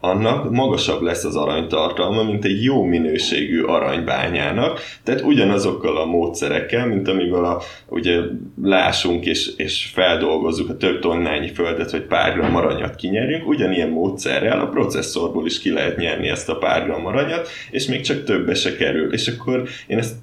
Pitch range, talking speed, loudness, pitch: 85-120 Hz, 155 wpm, -19 LUFS, 100 Hz